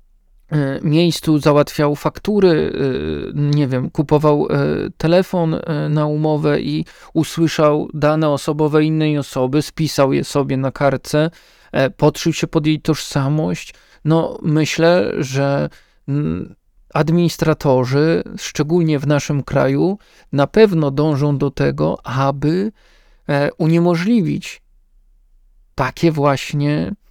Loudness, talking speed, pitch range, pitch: -17 LUFS, 95 wpm, 140-160 Hz, 150 Hz